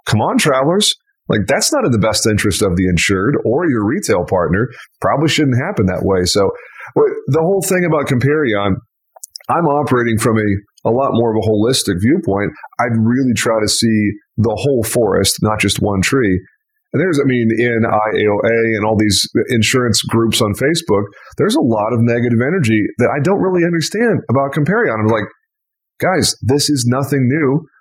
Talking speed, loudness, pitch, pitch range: 180 wpm, -15 LUFS, 120 Hz, 110-150 Hz